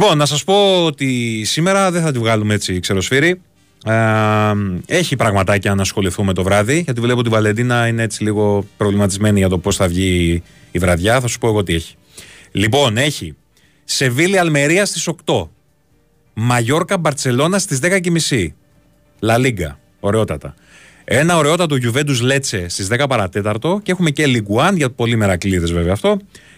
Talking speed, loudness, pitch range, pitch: 155 wpm, -16 LUFS, 100-150 Hz, 115 Hz